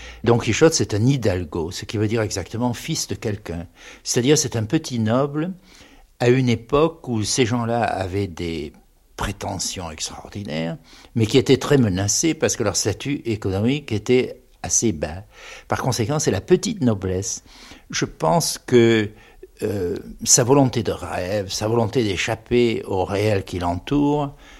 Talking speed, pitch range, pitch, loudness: 160 wpm, 100-130 Hz, 115 Hz, -21 LUFS